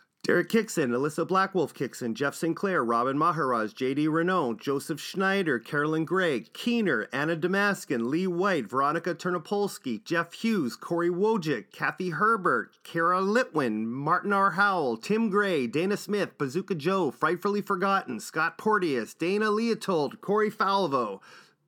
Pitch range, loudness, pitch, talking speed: 165-205 Hz, -27 LUFS, 185 Hz, 130 wpm